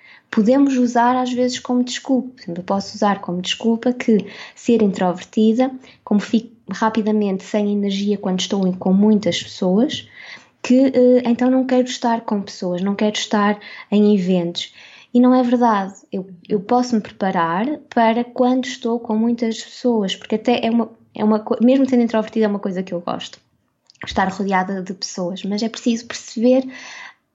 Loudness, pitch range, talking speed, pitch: -19 LUFS, 200-245 Hz, 160 wpm, 225 Hz